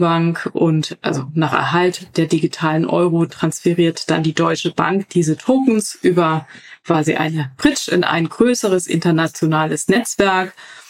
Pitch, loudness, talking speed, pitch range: 165 Hz, -17 LUFS, 130 wpm, 160-185 Hz